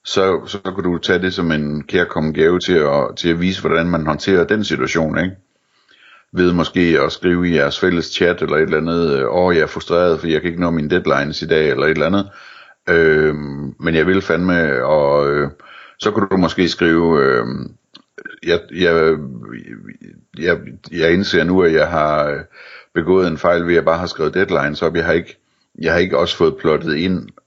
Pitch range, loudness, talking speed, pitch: 80-90 Hz, -16 LUFS, 190 wpm, 85 Hz